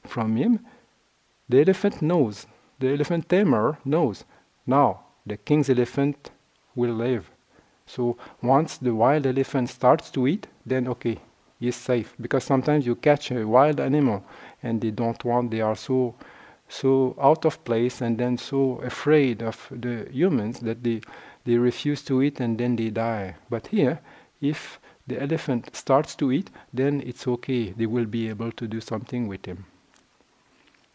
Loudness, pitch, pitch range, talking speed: -24 LUFS, 125 Hz, 115-135 Hz, 160 wpm